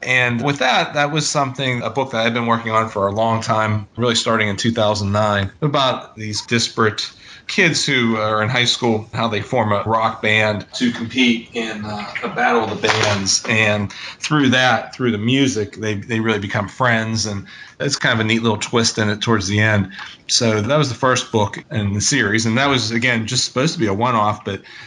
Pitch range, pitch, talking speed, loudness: 105-125 Hz, 115 Hz, 215 wpm, -18 LUFS